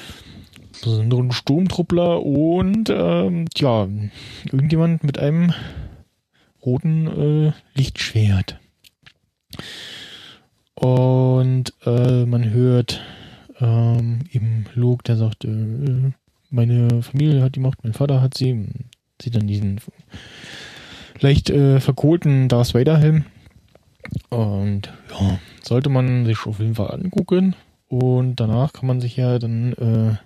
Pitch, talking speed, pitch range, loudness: 125 Hz, 110 wpm, 115-140 Hz, -19 LUFS